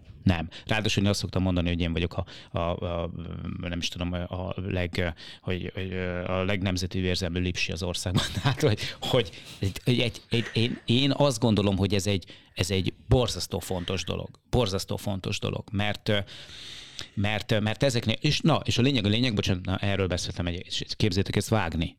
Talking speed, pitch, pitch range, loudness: 175 wpm, 100 Hz, 90-110 Hz, -28 LUFS